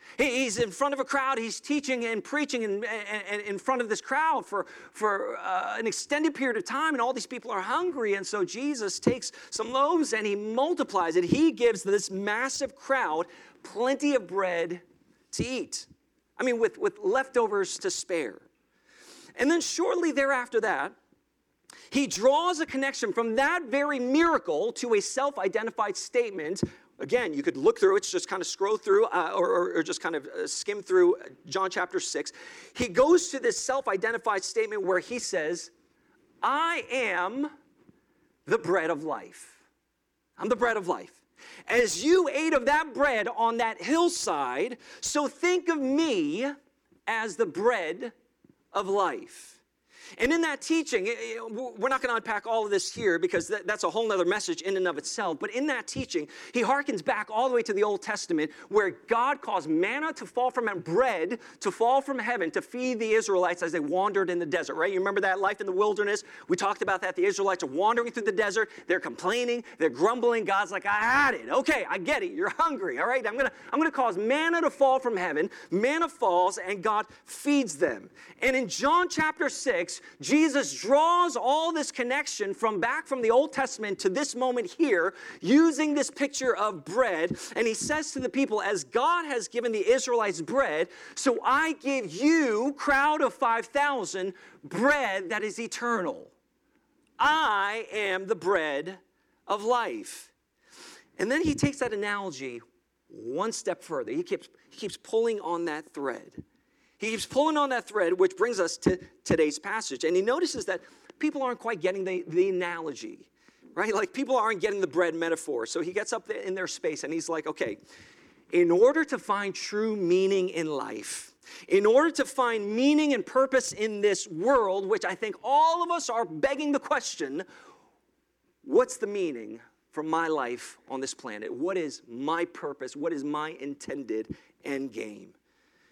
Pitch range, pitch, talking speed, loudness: 215-330 Hz, 265 Hz, 180 wpm, -27 LUFS